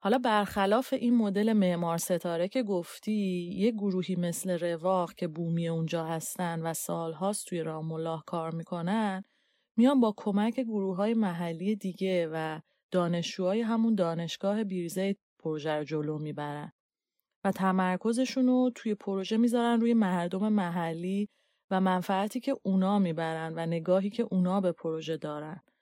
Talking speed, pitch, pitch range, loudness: 140 wpm, 185 Hz, 170-210 Hz, -30 LUFS